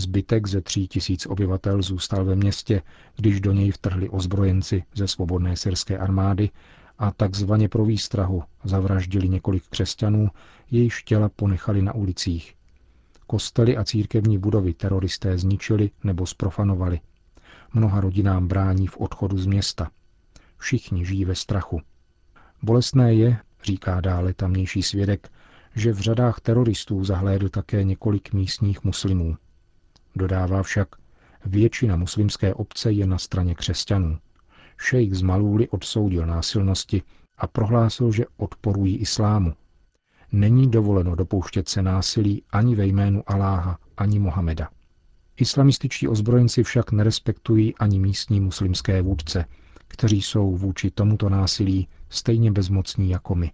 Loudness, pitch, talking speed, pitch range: -22 LUFS, 100 Hz, 125 wpm, 95-105 Hz